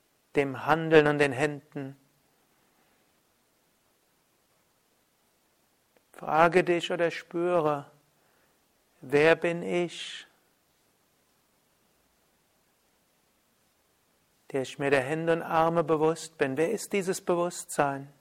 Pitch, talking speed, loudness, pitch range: 155 Hz, 80 wpm, -27 LUFS, 140-170 Hz